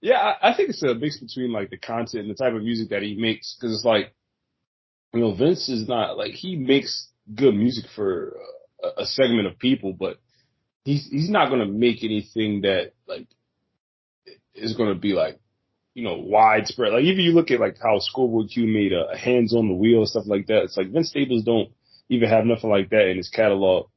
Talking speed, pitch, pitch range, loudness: 220 wpm, 115 Hz, 110-140 Hz, -22 LUFS